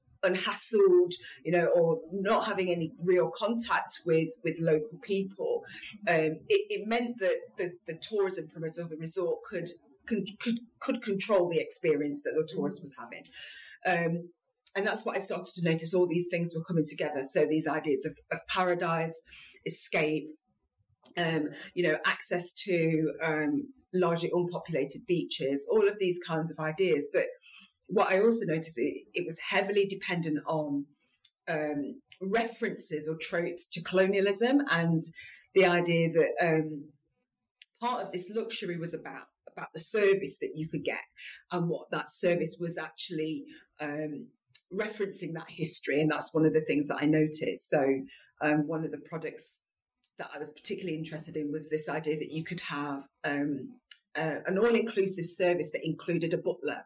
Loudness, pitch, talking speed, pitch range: -31 LUFS, 170 Hz, 165 wpm, 155-195 Hz